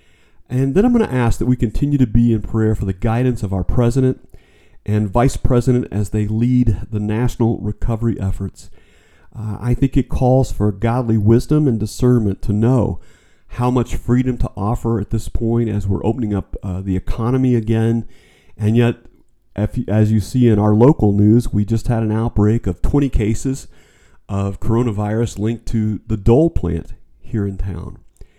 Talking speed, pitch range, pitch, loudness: 180 wpm, 105-120 Hz, 110 Hz, -18 LUFS